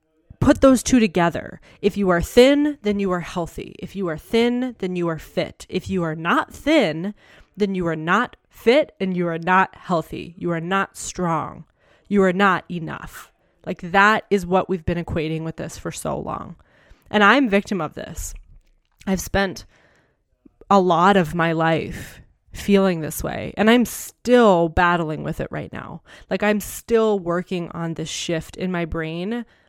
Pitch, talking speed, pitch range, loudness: 185 Hz, 180 wpm, 170-205 Hz, -20 LUFS